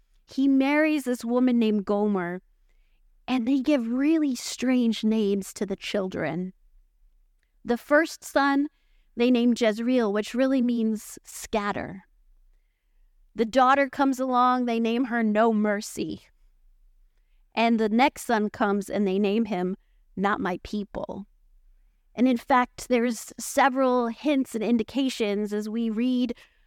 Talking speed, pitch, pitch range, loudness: 130 wpm, 235 Hz, 210-255 Hz, -25 LUFS